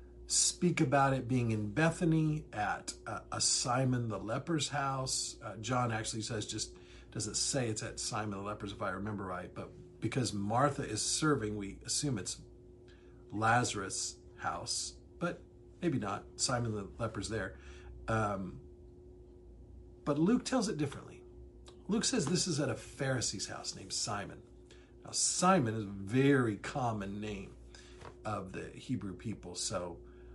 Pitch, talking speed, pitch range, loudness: 110 Hz, 145 wpm, 95-135 Hz, -34 LUFS